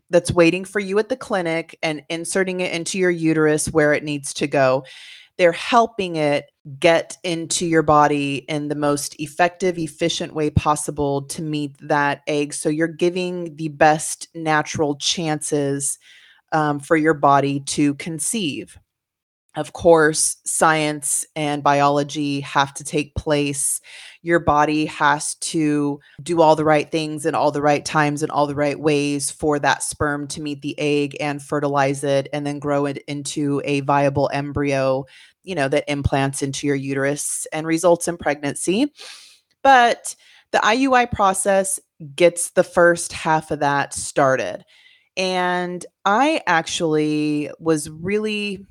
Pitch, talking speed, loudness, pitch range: 150 Hz, 150 wpm, -20 LUFS, 145-170 Hz